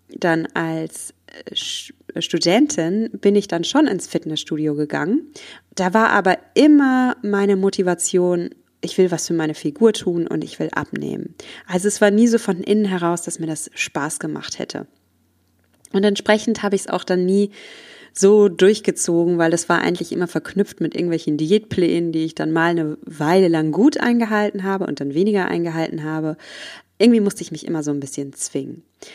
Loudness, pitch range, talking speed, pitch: -19 LUFS, 160-205 Hz, 175 wpm, 180 Hz